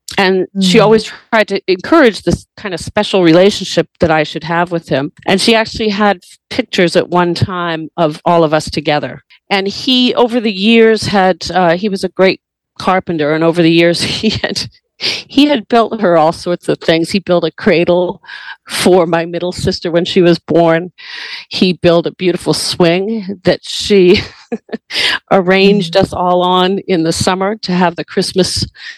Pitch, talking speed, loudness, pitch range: 185 Hz, 180 wpm, -12 LUFS, 170-200 Hz